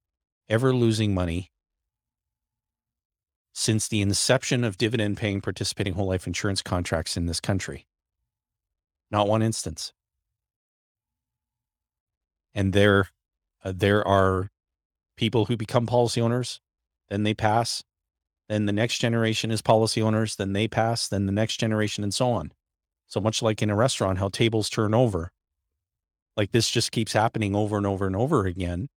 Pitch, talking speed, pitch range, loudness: 100 Hz, 145 wpm, 90-110 Hz, -25 LUFS